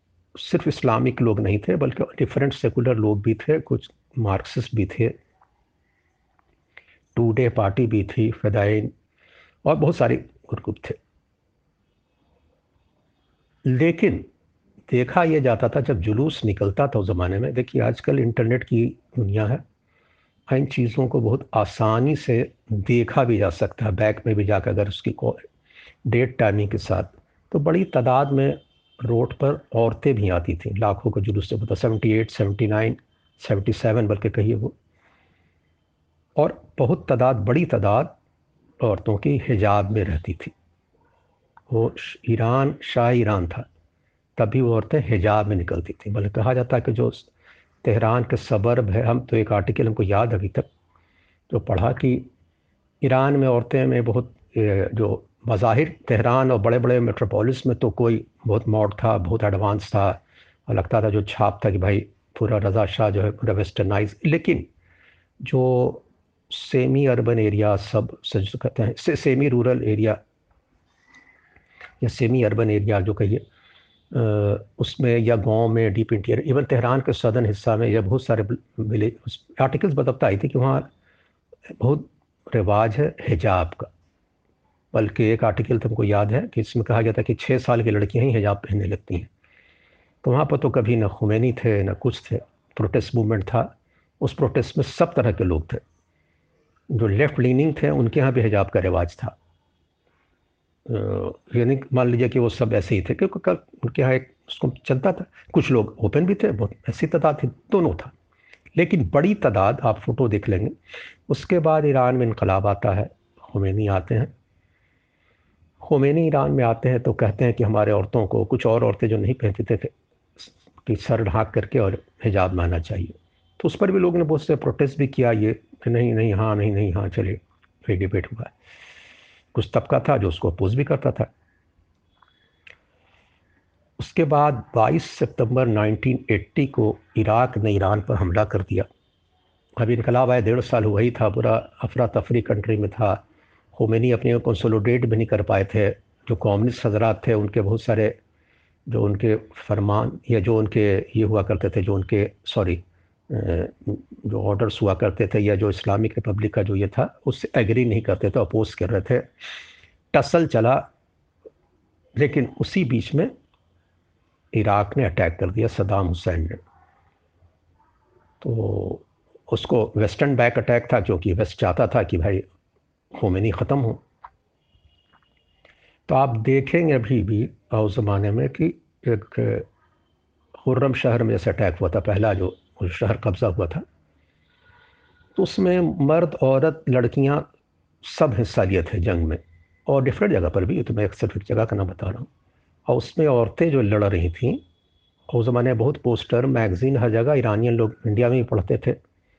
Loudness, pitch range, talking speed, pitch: -22 LUFS, 100-125 Hz, 165 wpm, 110 Hz